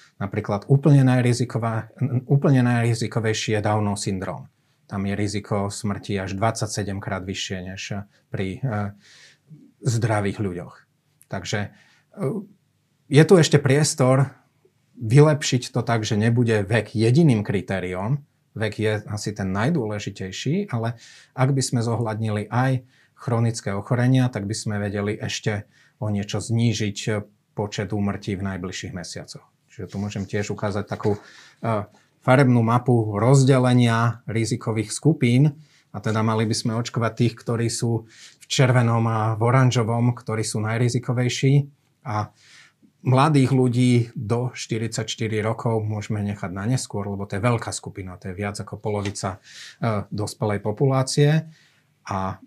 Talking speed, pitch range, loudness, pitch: 125 wpm, 105-130 Hz, -22 LUFS, 115 Hz